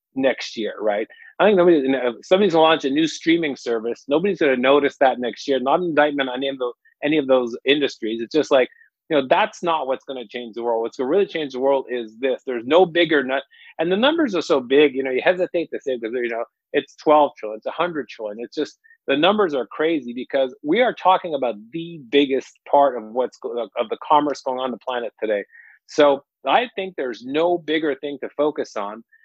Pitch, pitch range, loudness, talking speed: 145 Hz, 130-170 Hz, -21 LUFS, 230 wpm